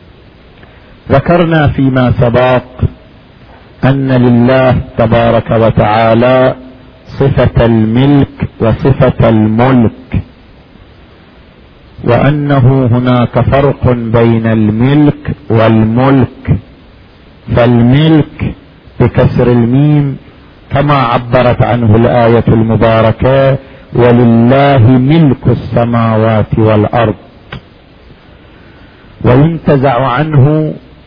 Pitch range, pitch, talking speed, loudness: 115-135 Hz, 120 Hz, 60 wpm, -9 LUFS